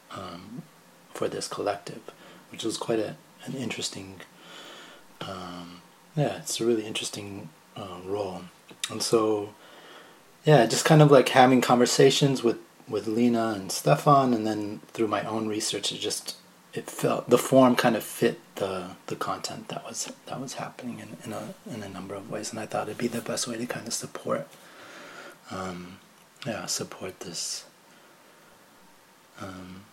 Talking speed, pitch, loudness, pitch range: 160 wpm, 110 Hz, -26 LUFS, 95-125 Hz